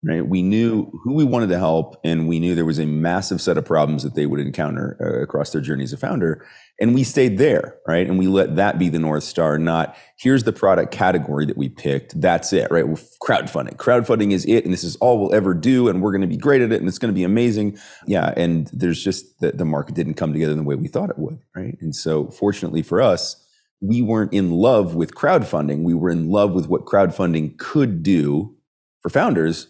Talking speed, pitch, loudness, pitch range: 240 wpm, 85 Hz, -19 LUFS, 80-100 Hz